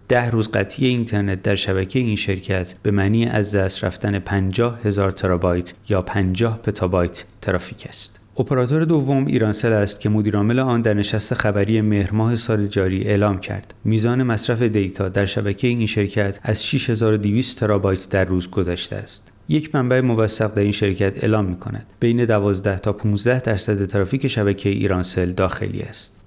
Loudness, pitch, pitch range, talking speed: -20 LUFS, 105 Hz, 100-115 Hz, 160 wpm